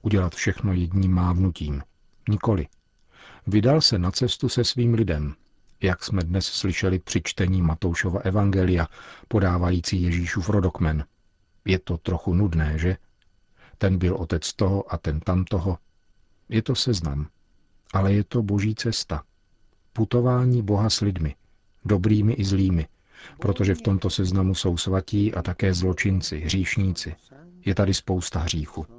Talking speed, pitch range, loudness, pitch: 135 wpm, 90-105 Hz, -24 LUFS, 95 Hz